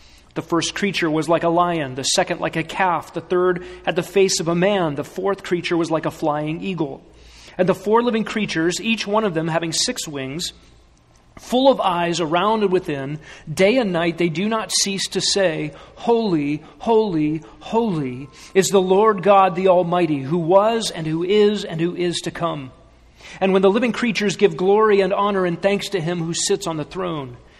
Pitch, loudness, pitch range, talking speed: 175 Hz, -19 LUFS, 160-195 Hz, 200 wpm